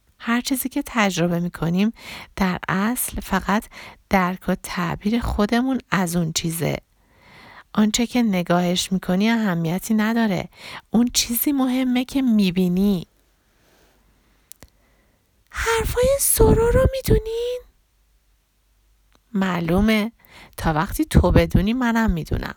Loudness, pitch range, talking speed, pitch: -21 LUFS, 180-245 Hz, 110 wpm, 210 Hz